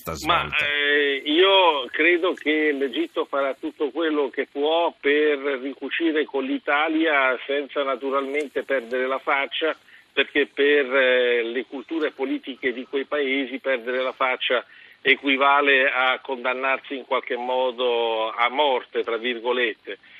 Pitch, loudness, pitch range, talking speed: 140 Hz, -22 LUFS, 130-145 Hz, 125 wpm